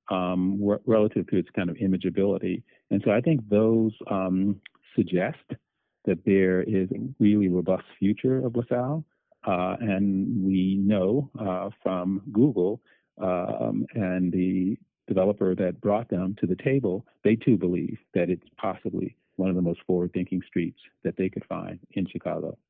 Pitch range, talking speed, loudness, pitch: 95-110 Hz, 155 wpm, -26 LUFS, 95 Hz